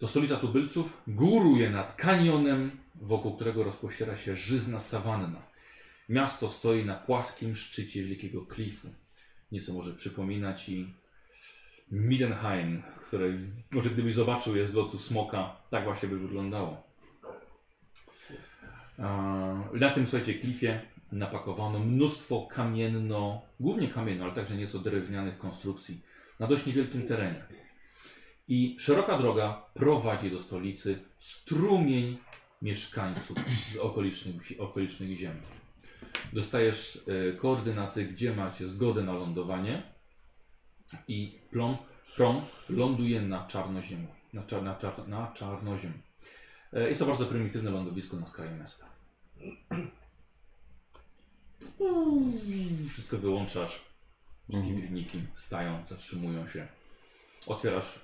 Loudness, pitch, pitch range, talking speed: -32 LUFS, 105 Hz, 95-120 Hz, 100 wpm